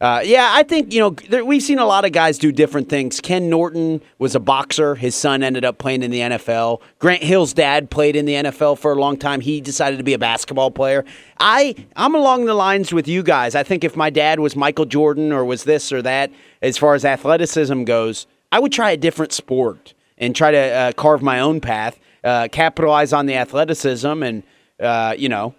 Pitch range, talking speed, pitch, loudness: 130-165 Hz, 225 wpm, 145 Hz, -17 LUFS